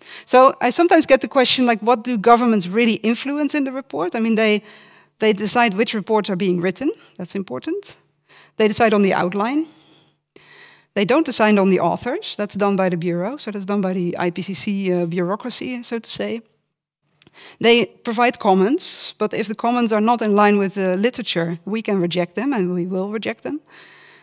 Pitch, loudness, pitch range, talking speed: 215 Hz, -19 LUFS, 190-240 Hz, 190 wpm